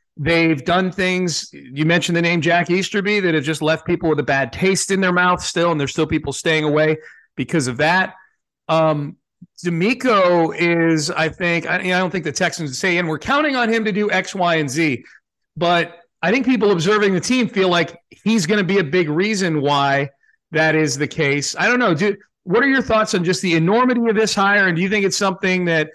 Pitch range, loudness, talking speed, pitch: 160-195 Hz, -18 LUFS, 225 wpm, 175 Hz